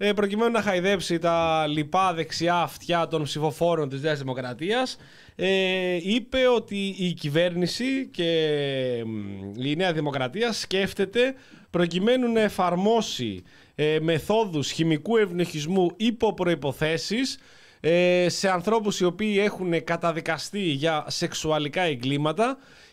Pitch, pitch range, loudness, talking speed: 175 Hz, 155-205 Hz, -25 LUFS, 100 wpm